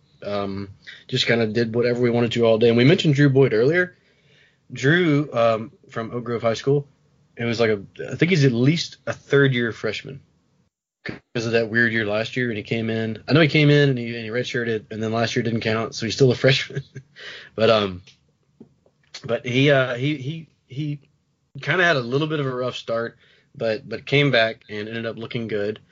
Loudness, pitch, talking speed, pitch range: -21 LUFS, 125 Hz, 220 wpm, 115-145 Hz